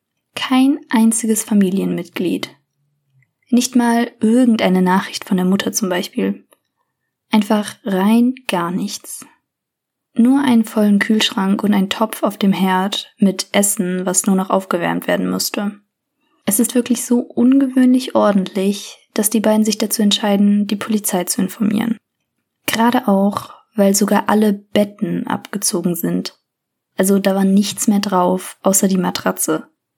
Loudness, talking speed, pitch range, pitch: -16 LUFS, 135 wpm, 190-230 Hz, 205 Hz